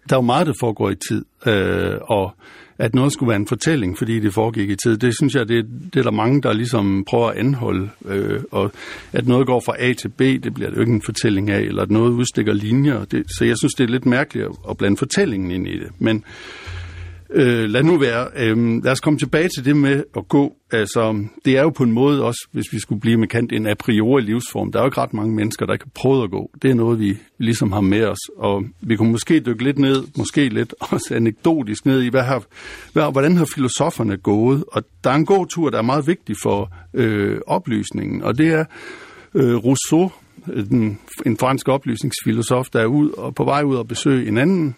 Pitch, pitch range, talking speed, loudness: 120 Hz, 110-135 Hz, 230 wpm, -19 LUFS